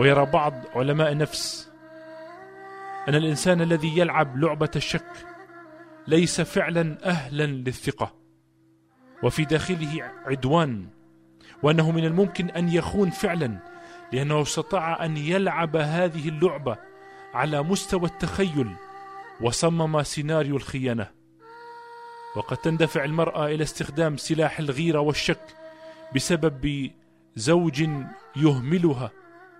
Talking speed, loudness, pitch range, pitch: 95 wpm, -25 LUFS, 145-195 Hz, 160 Hz